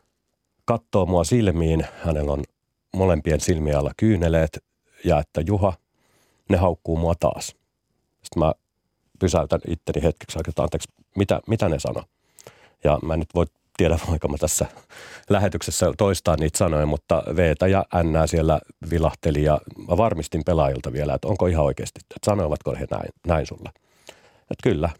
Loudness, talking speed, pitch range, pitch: -23 LUFS, 150 wpm, 75-90 Hz, 80 Hz